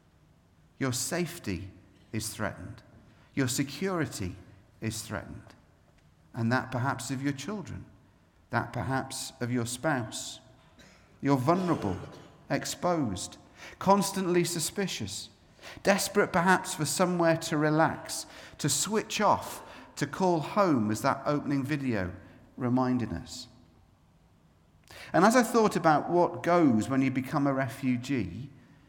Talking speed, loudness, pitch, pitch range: 110 wpm, -29 LUFS, 135 Hz, 110-165 Hz